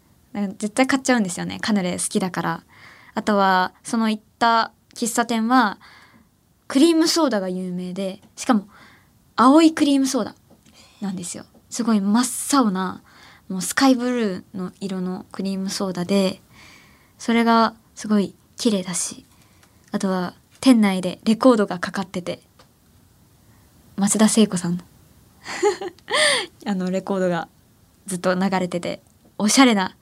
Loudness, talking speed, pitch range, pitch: -21 LUFS, 280 characters per minute, 185-235 Hz, 200 Hz